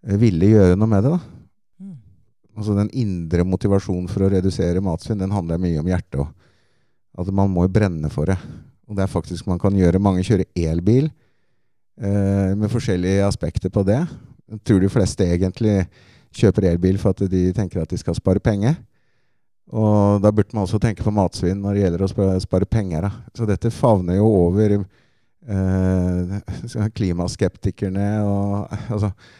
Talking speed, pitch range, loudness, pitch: 165 wpm, 95-105 Hz, -20 LUFS, 100 Hz